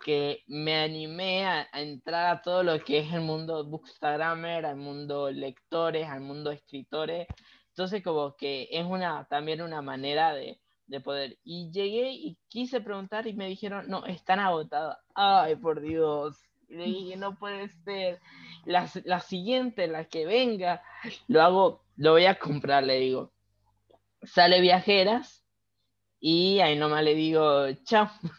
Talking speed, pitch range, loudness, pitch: 155 wpm, 145-190 Hz, -27 LUFS, 165 Hz